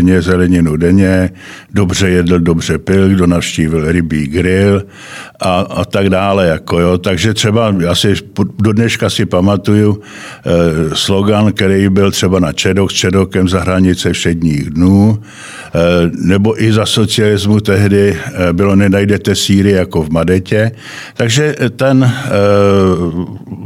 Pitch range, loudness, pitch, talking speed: 90-105 Hz, -11 LUFS, 95 Hz, 130 wpm